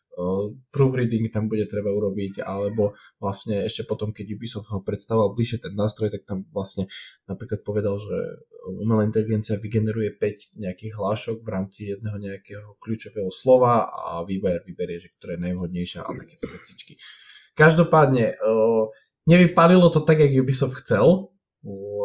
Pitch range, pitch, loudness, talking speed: 100-115 Hz, 105 Hz, -23 LUFS, 145 wpm